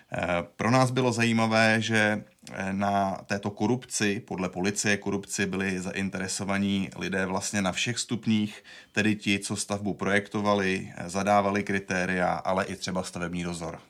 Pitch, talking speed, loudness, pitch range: 100 Hz, 130 wpm, -27 LUFS, 95-105 Hz